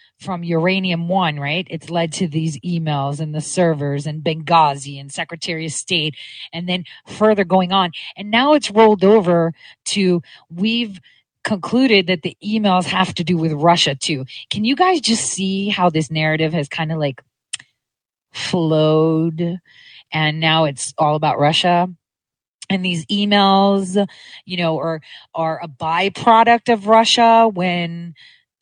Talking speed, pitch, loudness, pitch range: 150 wpm, 175 Hz, -17 LUFS, 160-195 Hz